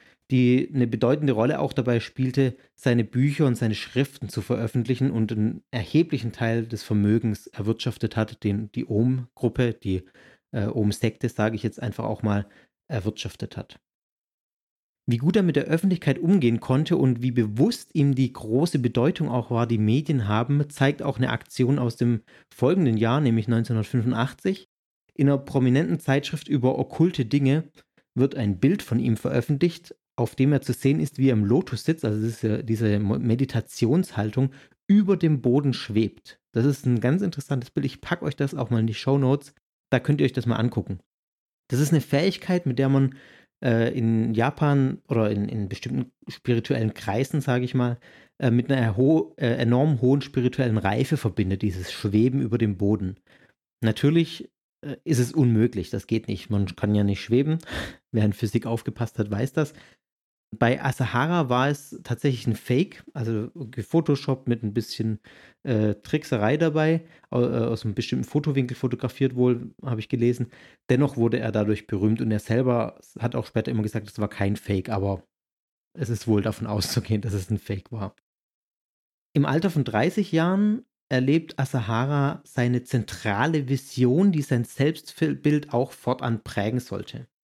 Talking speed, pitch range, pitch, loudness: 170 wpm, 110-140 Hz, 125 Hz, -24 LUFS